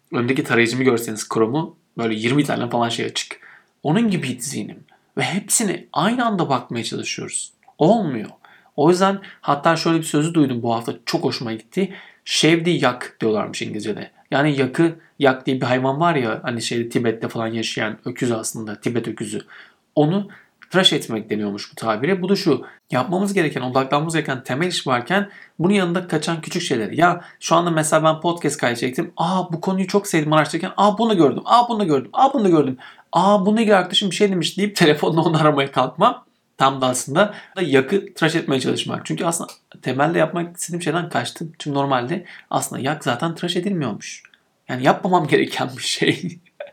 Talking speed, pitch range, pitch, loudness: 175 wpm, 130-185 Hz, 160 Hz, -20 LUFS